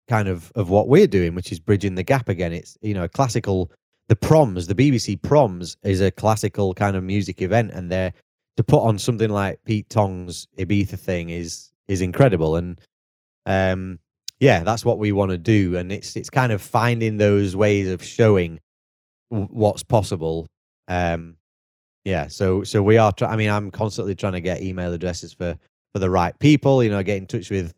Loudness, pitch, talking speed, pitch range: -21 LUFS, 100 Hz, 200 wpm, 90-110 Hz